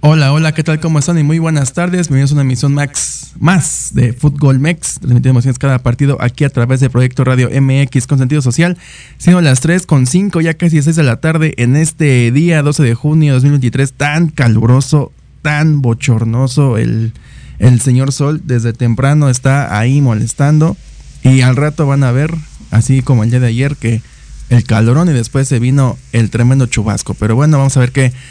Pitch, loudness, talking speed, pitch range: 135 Hz, -11 LUFS, 195 wpm, 125-150 Hz